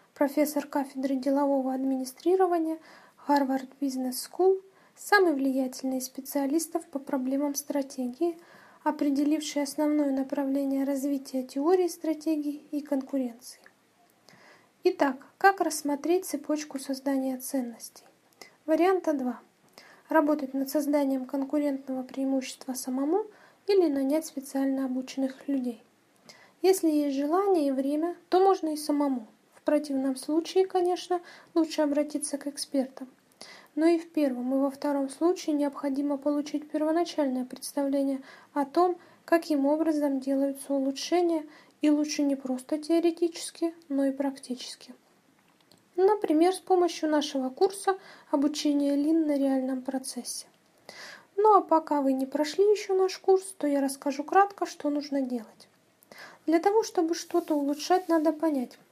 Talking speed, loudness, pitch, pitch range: 120 wpm, -28 LUFS, 290 Hz, 275-330 Hz